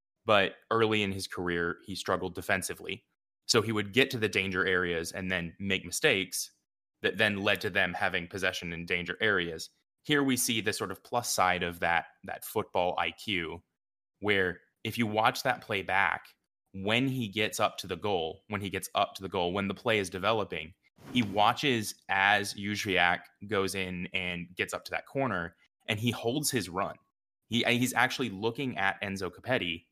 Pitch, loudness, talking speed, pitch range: 100 Hz, -30 LUFS, 185 wpm, 95-115 Hz